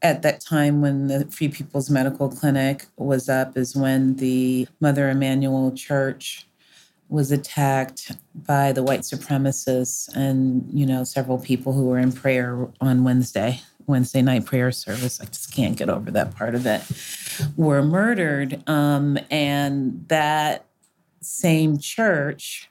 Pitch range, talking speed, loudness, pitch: 130-145 Hz, 145 wpm, -22 LUFS, 135 Hz